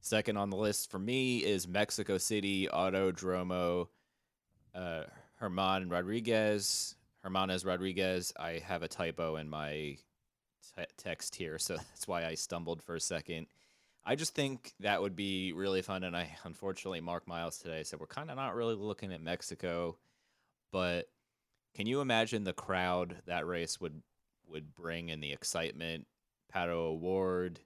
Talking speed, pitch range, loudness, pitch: 155 wpm, 85-100 Hz, -37 LUFS, 90 Hz